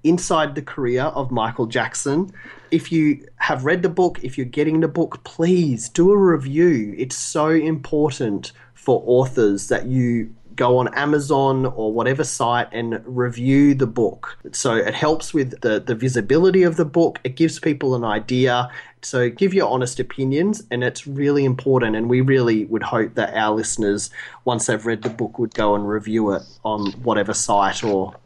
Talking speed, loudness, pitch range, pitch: 180 wpm, -20 LUFS, 115-155 Hz, 130 Hz